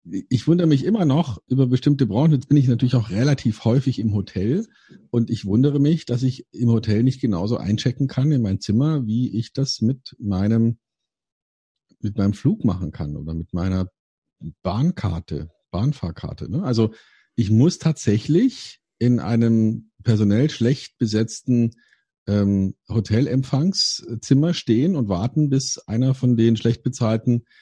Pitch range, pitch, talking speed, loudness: 110-135 Hz, 120 Hz, 145 wpm, -21 LUFS